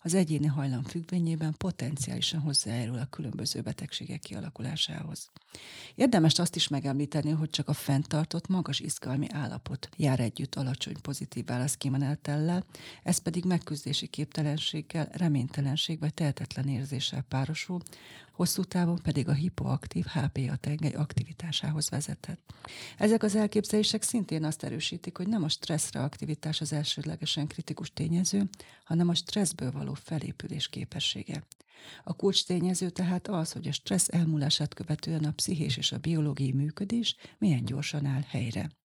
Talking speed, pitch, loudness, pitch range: 130 wpm, 155 Hz, -31 LUFS, 145-175 Hz